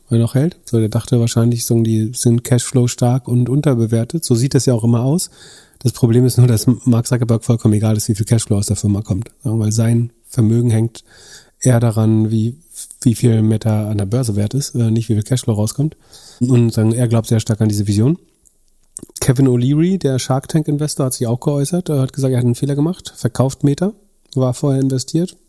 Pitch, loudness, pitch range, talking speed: 120 Hz, -16 LUFS, 115-135 Hz, 210 wpm